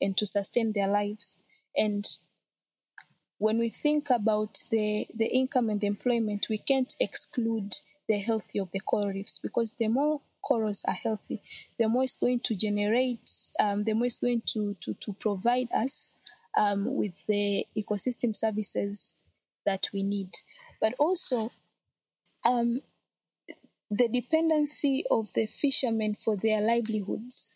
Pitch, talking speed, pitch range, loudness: 220 Hz, 145 wpm, 205-245 Hz, -27 LUFS